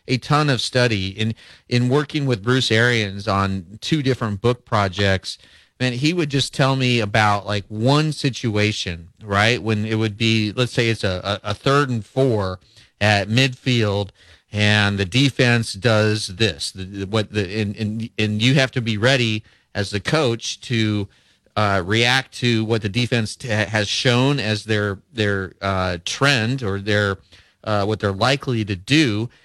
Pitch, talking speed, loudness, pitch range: 110 Hz, 170 wpm, -20 LUFS, 105-125 Hz